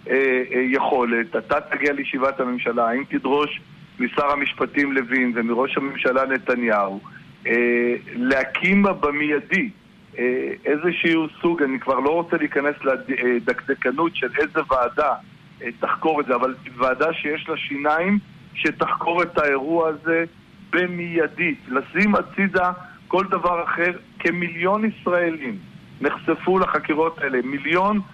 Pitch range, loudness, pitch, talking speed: 130-170 Hz, -21 LUFS, 150 Hz, 105 wpm